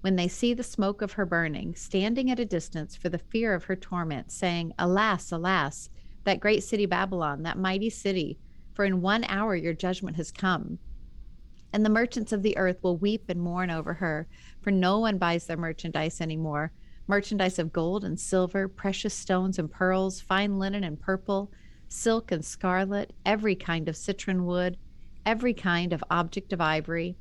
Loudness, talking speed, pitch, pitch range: -28 LUFS, 180 wpm, 185 Hz, 170-200 Hz